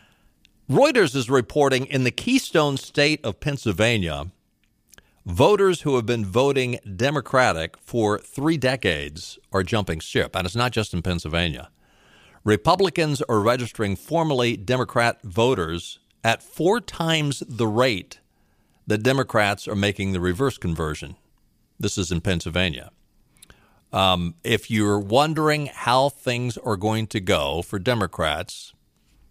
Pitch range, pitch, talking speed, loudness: 95-130 Hz, 110 Hz, 125 wpm, -22 LUFS